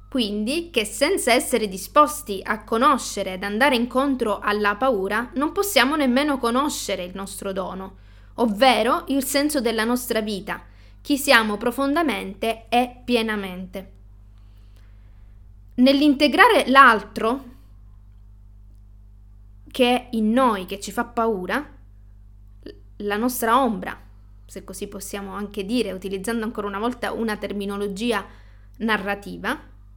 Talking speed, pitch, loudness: 110 wpm, 210 Hz, -21 LUFS